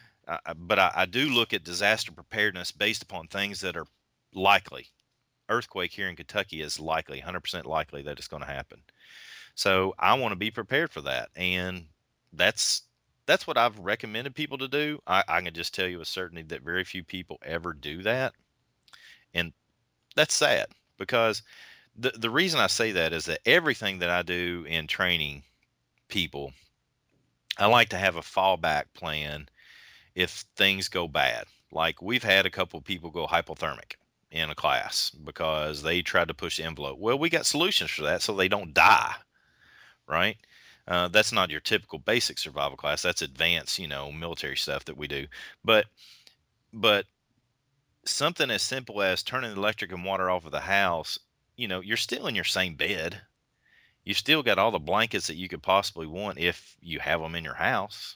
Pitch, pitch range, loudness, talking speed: 90 Hz, 80-100 Hz, -27 LUFS, 185 wpm